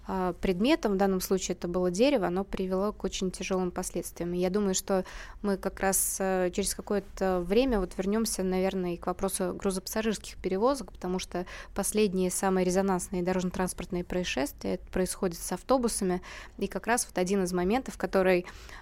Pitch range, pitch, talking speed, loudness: 180-200 Hz, 190 Hz, 155 wpm, -29 LUFS